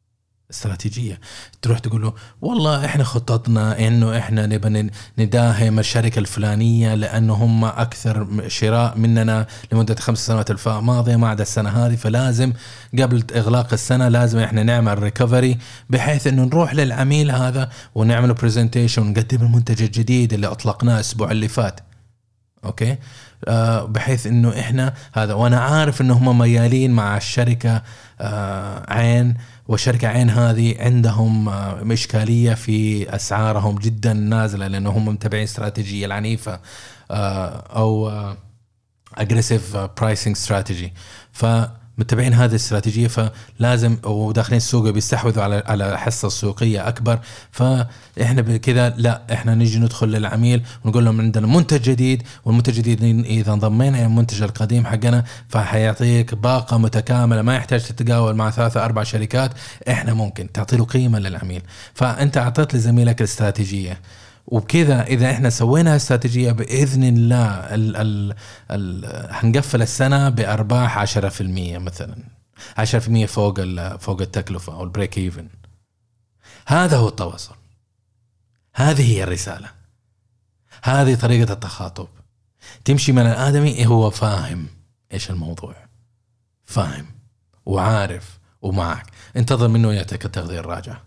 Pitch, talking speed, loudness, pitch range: 115 Hz, 120 wpm, -18 LUFS, 105-120 Hz